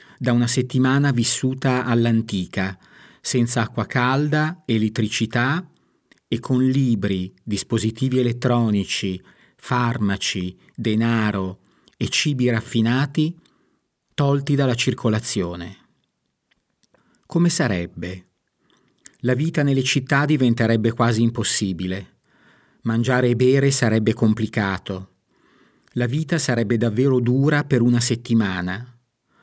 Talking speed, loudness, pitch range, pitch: 90 wpm, -21 LUFS, 110-130 Hz, 120 Hz